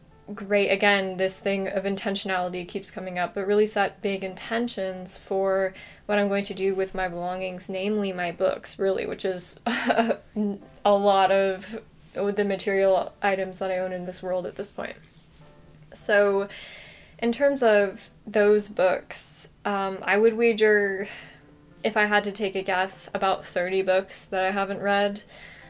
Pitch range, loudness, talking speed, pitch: 185-205 Hz, -25 LUFS, 160 wpm, 195 Hz